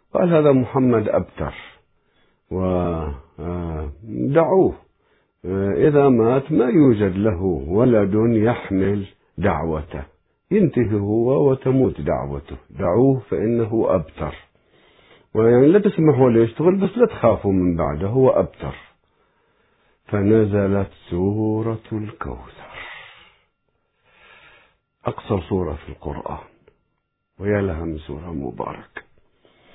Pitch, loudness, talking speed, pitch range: 100 Hz, -19 LUFS, 85 wpm, 85-125 Hz